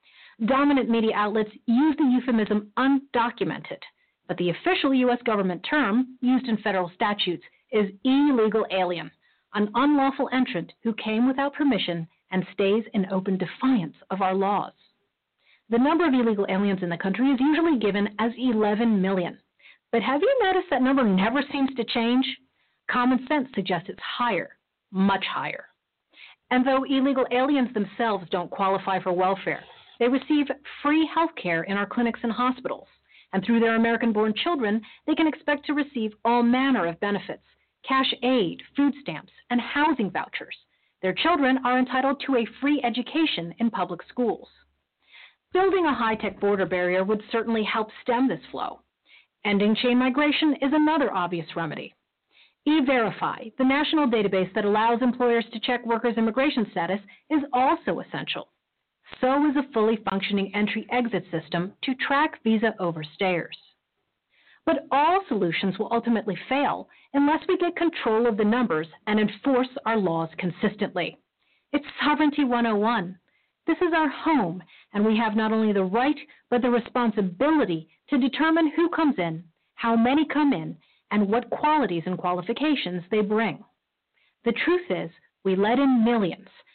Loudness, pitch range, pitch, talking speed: -24 LUFS, 200-275 Hz, 235 Hz, 155 wpm